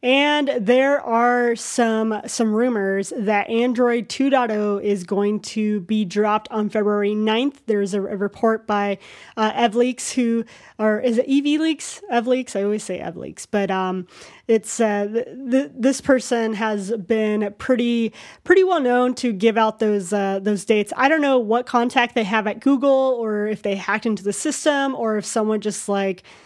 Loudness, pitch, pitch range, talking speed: -20 LUFS, 225 Hz, 210-250 Hz, 170 wpm